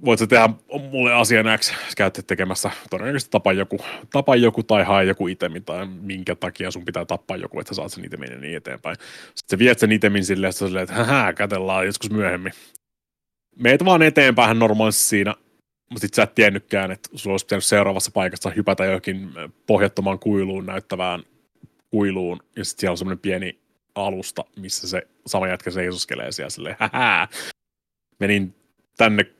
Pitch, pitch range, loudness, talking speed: 100 Hz, 95-110 Hz, -20 LUFS, 165 wpm